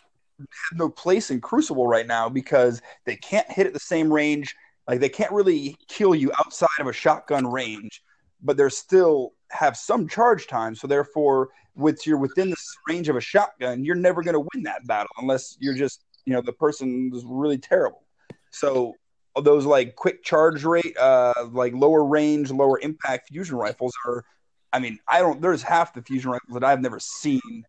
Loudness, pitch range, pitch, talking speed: -23 LUFS, 130-185 Hz, 150 Hz, 190 wpm